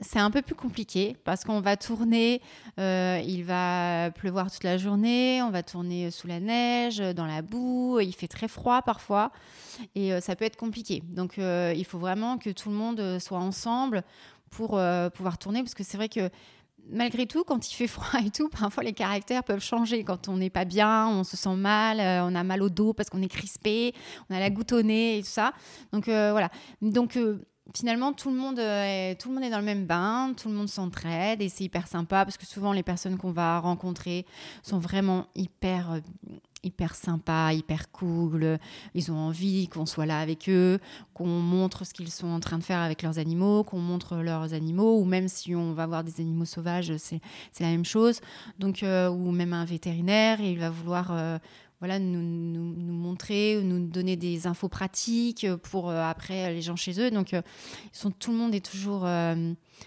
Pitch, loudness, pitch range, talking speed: 190 Hz, -28 LUFS, 175-215 Hz, 215 wpm